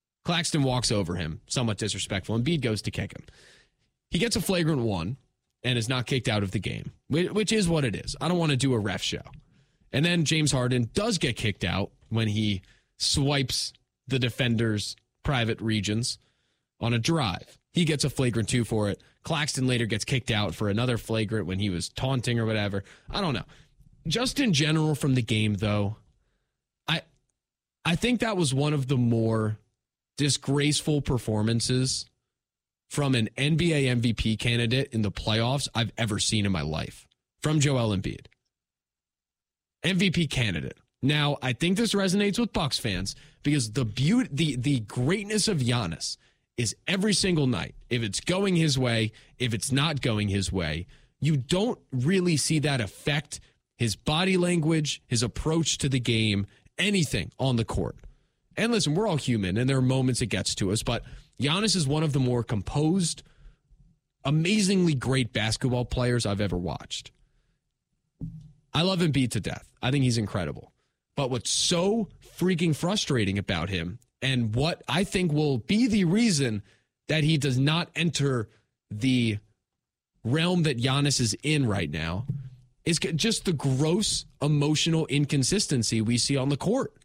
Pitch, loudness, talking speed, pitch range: 130 Hz, -26 LUFS, 170 wpm, 110-155 Hz